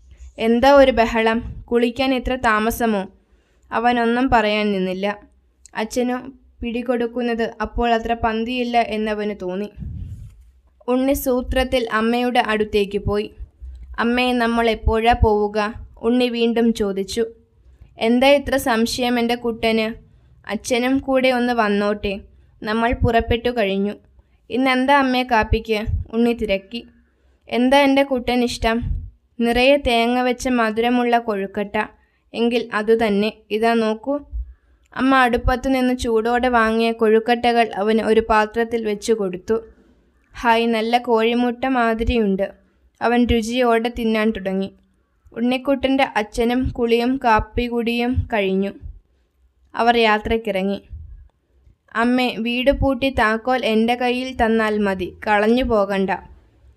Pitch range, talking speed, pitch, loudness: 210-245 Hz, 100 wpm, 230 Hz, -19 LUFS